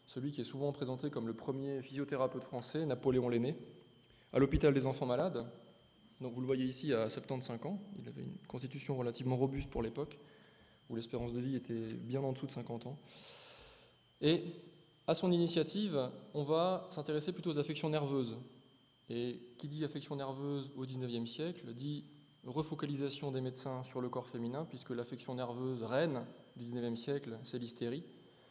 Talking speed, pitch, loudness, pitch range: 170 wpm, 135 Hz, -39 LUFS, 125-145 Hz